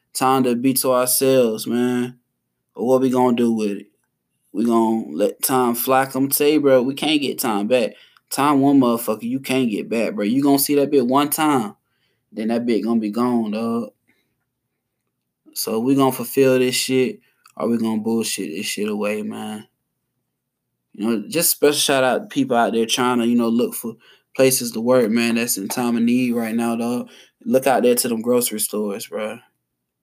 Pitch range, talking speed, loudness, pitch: 115-130 Hz, 195 wpm, -19 LUFS, 125 Hz